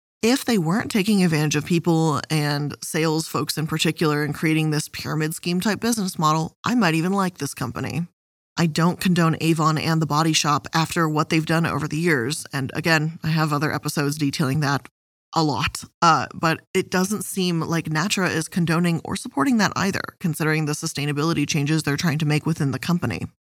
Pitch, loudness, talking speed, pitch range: 160 Hz, -22 LUFS, 190 wpm, 150-175 Hz